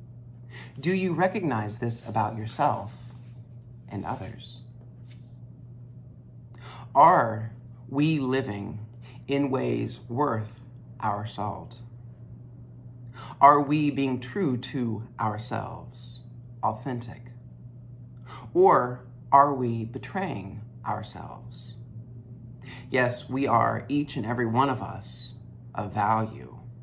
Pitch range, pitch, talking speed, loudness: 115-125 Hz, 120 Hz, 85 wpm, -26 LUFS